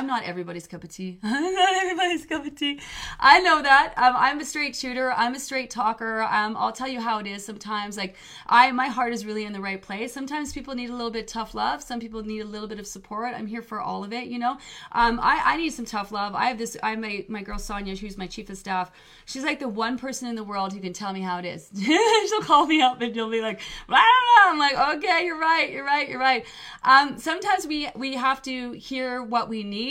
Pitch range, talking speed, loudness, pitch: 210-275 Hz, 265 wpm, -23 LUFS, 240 Hz